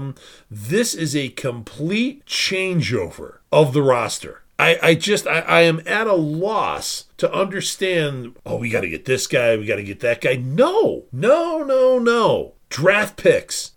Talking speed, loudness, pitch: 155 wpm, -19 LUFS, 165 Hz